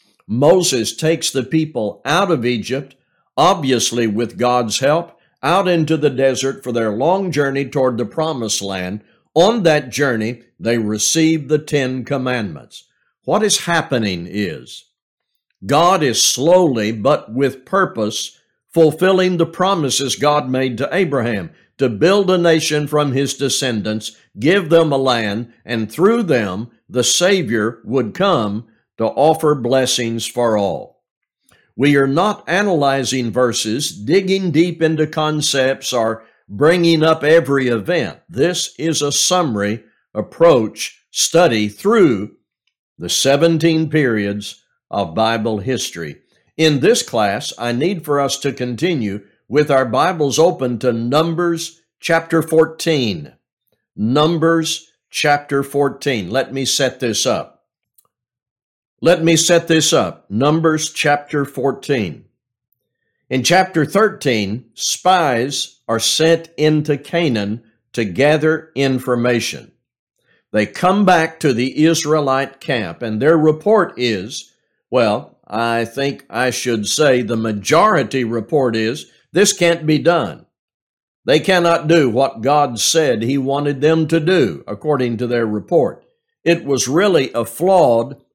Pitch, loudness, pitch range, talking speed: 140 Hz, -16 LUFS, 120-165 Hz, 125 wpm